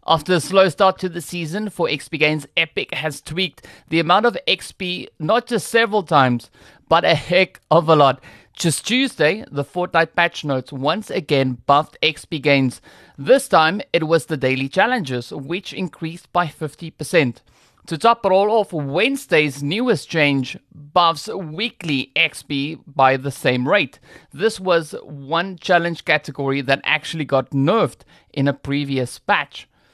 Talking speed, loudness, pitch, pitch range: 155 wpm, -19 LUFS, 160 Hz, 140-185 Hz